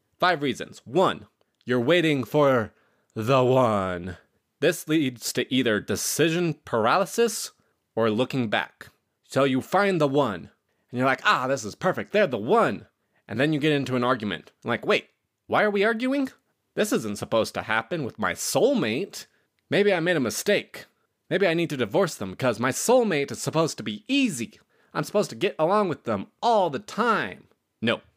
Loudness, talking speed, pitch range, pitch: -24 LUFS, 180 wpm, 120-175 Hz, 140 Hz